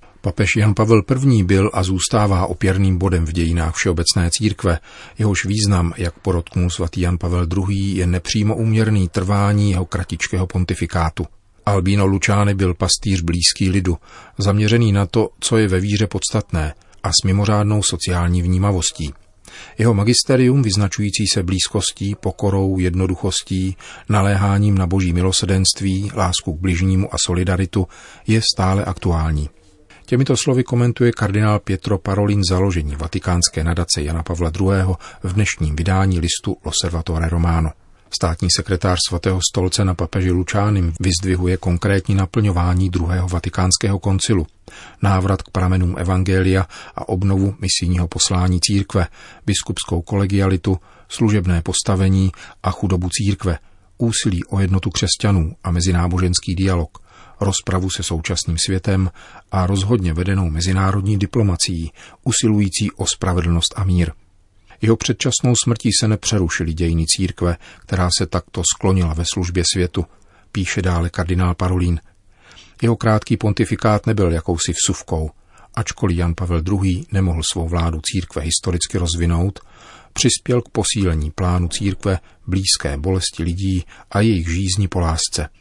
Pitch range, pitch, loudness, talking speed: 90-100 Hz, 95 Hz, -18 LUFS, 125 wpm